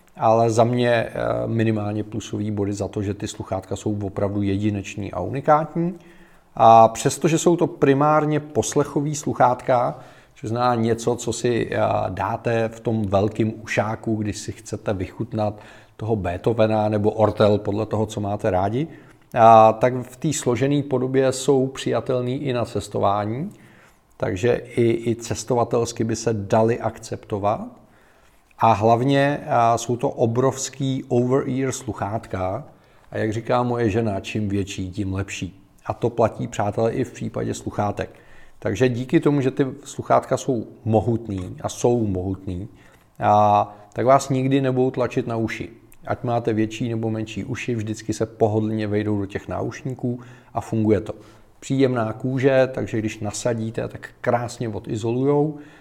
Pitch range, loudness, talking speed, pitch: 105-130 Hz, -22 LUFS, 140 wpm, 115 Hz